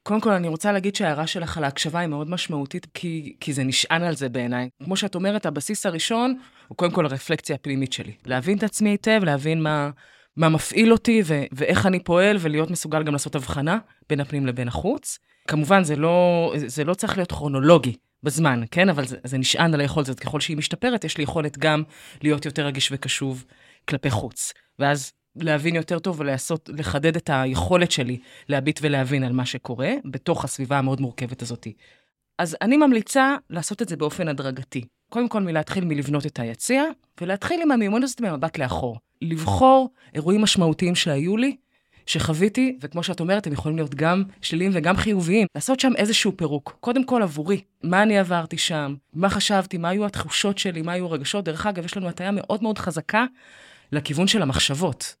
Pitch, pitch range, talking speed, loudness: 165 Hz, 145-195 Hz, 185 wpm, -23 LUFS